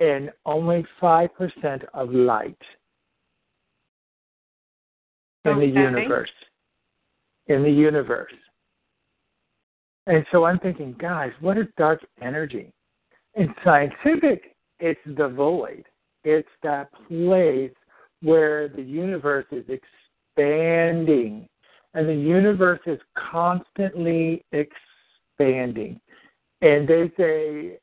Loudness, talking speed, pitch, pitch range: -22 LUFS, 90 wpm, 155 Hz, 145-170 Hz